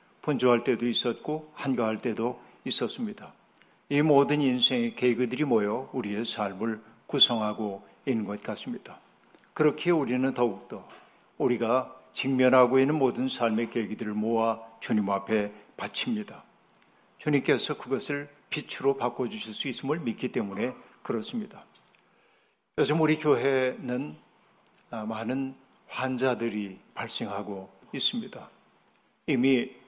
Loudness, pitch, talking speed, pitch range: -28 LUFS, 125 Hz, 265 characters per minute, 110-135 Hz